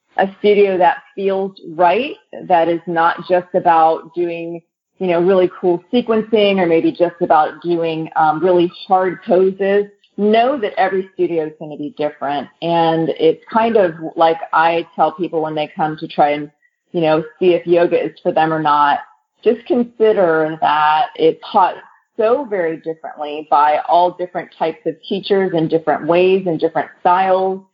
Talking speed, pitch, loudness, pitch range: 170 wpm, 175 Hz, -16 LUFS, 160-190 Hz